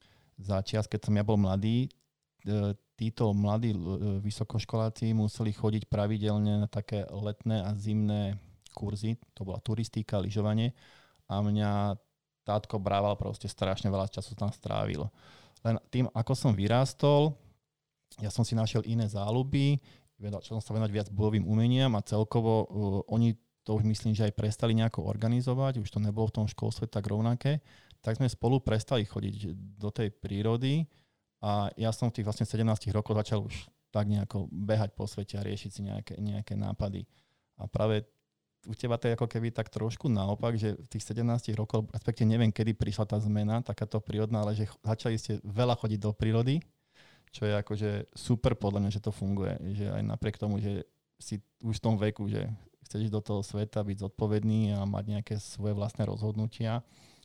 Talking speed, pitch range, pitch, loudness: 170 wpm, 105-115 Hz, 110 Hz, -32 LUFS